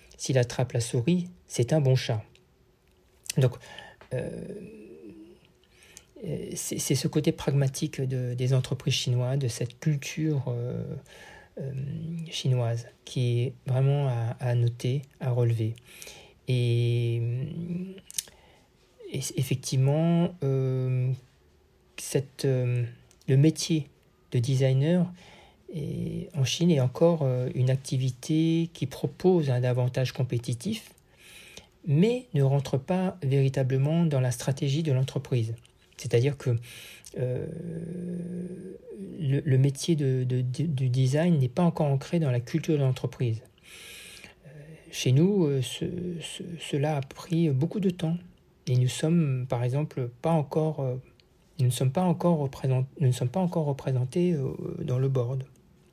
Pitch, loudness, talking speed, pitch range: 140 Hz, -28 LUFS, 120 wpm, 125-165 Hz